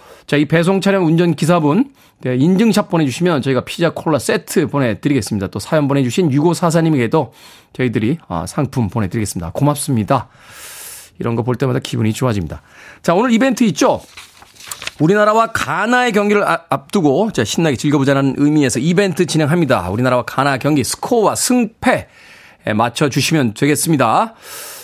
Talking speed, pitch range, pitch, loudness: 360 characters per minute, 125-175 Hz, 145 Hz, -15 LUFS